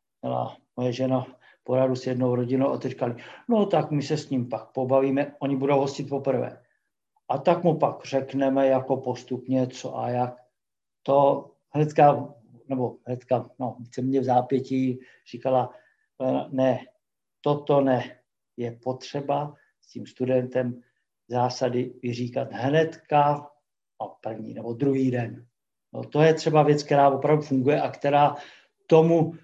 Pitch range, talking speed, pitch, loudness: 125-145 Hz, 135 wpm, 130 Hz, -25 LUFS